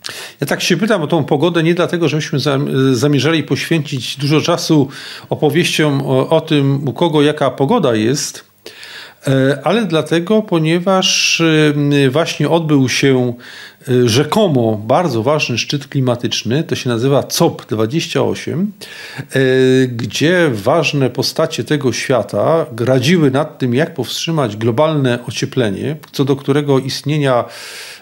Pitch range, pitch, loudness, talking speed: 130-165 Hz, 145 Hz, -14 LUFS, 115 wpm